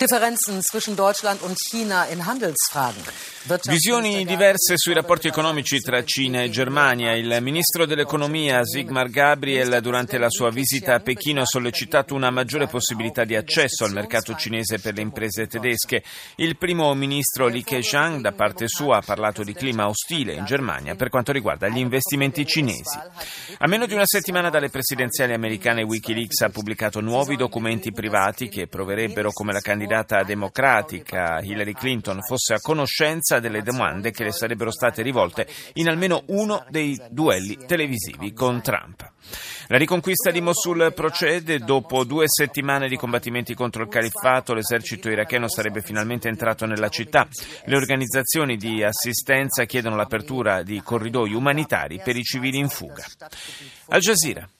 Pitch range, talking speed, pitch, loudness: 115-150 Hz, 155 wpm, 125 Hz, -21 LUFS